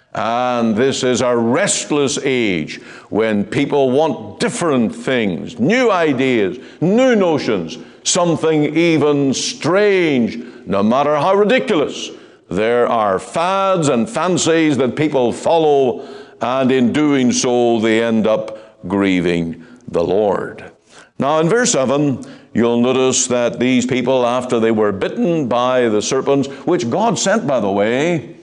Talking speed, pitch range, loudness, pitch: 130 wpm, 120-150 Hz, -16 LUFS, 130 Hz